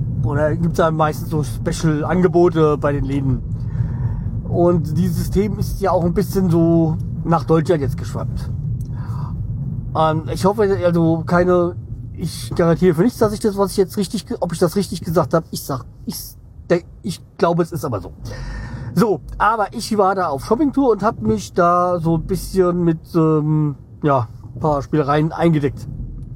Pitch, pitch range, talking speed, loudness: 160 Hz, 130-175 Hz, 175 wpm, -18 LUFS